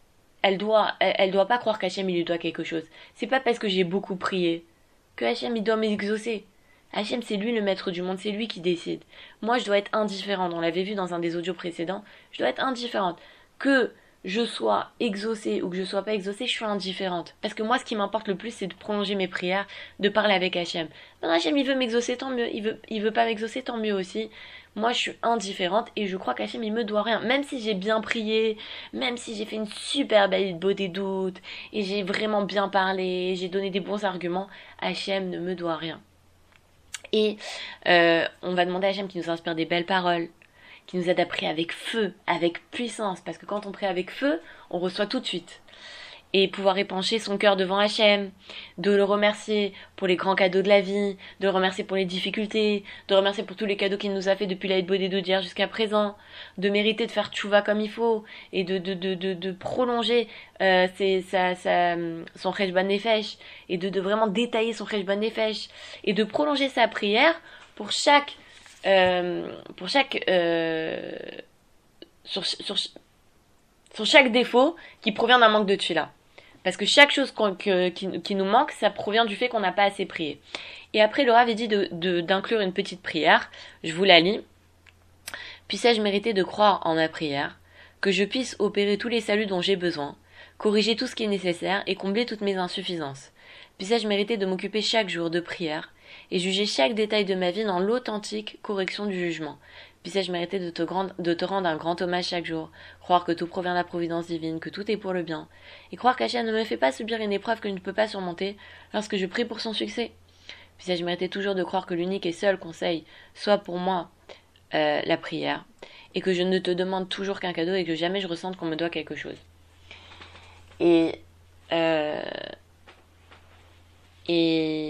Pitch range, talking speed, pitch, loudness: 175-215 Hz, 210 wpm, 195 Hz, -25 LUFS